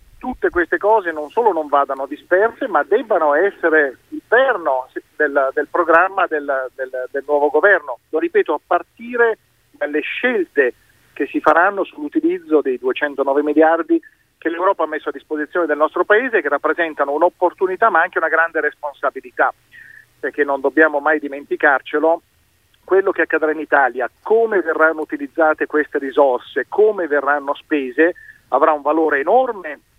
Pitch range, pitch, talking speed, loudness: 145-210 Hz, 160 Hz, 145 wpm, -17 LUFS